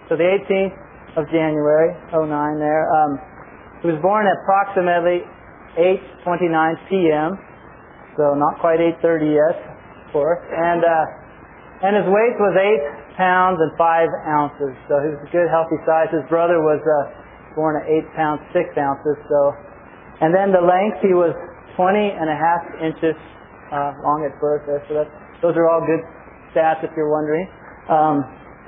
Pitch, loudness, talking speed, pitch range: 160 Hz, -18 LUFS, 165 wpm, 150-175 Hz